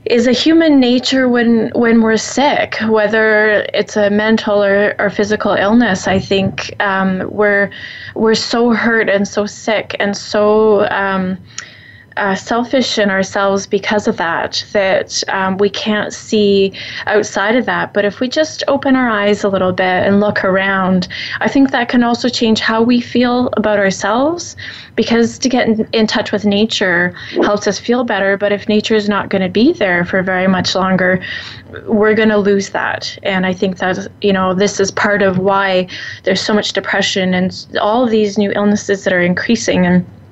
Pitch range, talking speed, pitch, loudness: 195-225 Hz, 185 wpm, 205 Hz, -13 LUFS